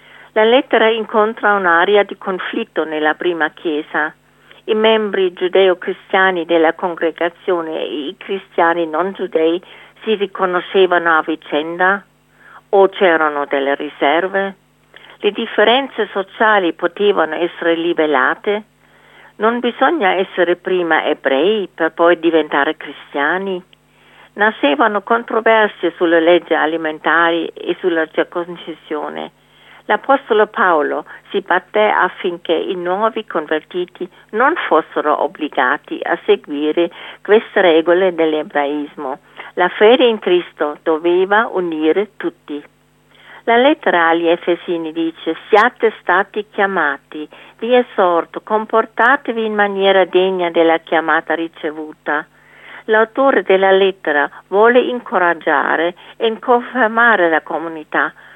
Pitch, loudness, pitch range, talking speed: 180 Hz, -15 LUFS, 165-215 Hz, 100 wpm